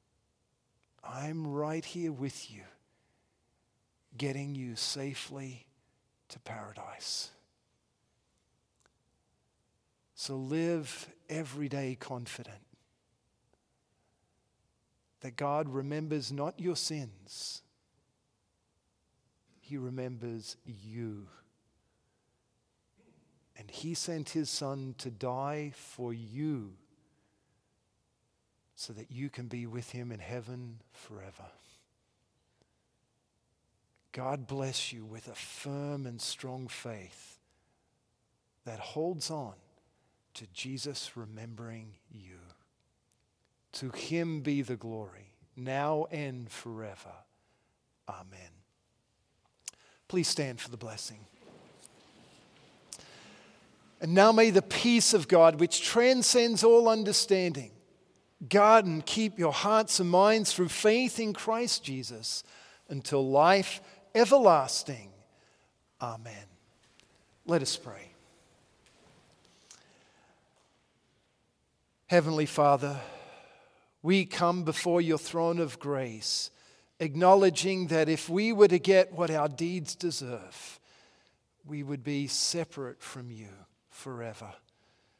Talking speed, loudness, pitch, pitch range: 90 wpm, -28 LUFS, 135 Hz, 115-165 Hz